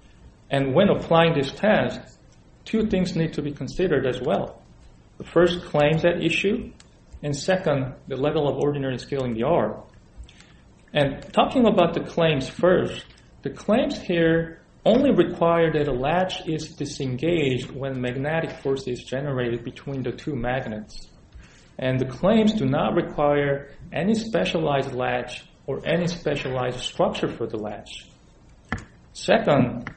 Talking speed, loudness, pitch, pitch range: 140 wpm, -23 LUFS, 150 Hz, 130-175 Hz